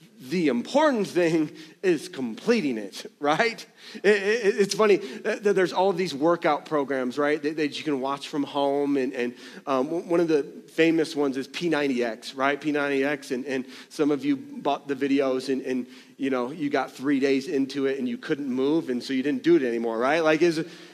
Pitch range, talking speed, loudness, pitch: 135-175 Hz, 200 wpm, -25 LUFS, 145 Hz